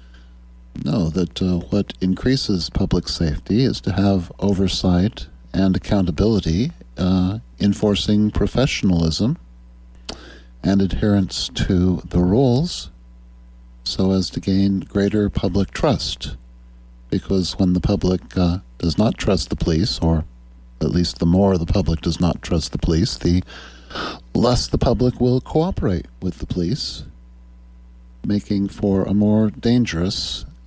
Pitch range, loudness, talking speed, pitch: 70-100 Hz, -20 LUFS, 125 wpm, 90 Hz